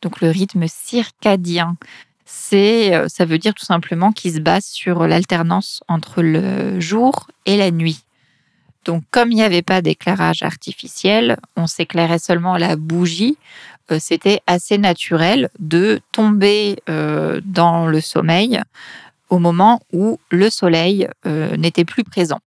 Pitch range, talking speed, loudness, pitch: 165-205 Hz, 135 wpm, -16 LUFS, 175 Hz